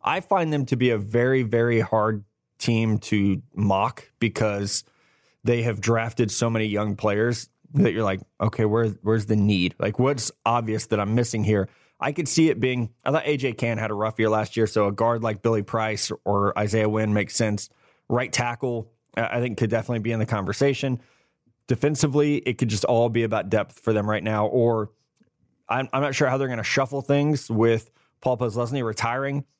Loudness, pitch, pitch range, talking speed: -24 LUFS, 115 Hz, 110-125 Hz, 200 wpm